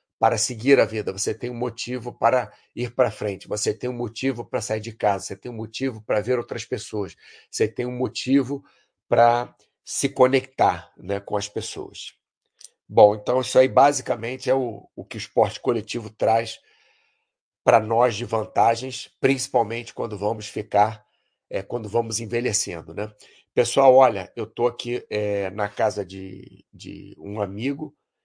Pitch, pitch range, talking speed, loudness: 120 Hz, 105-130 Hz, 165 wpm, -23 LUFS